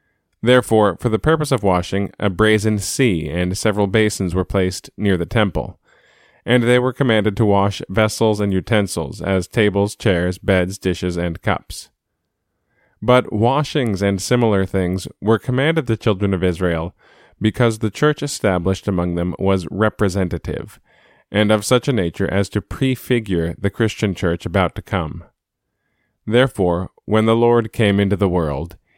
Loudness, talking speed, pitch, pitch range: -18 LUFS, 155 wpm, 100 Hz, 95-110 Hz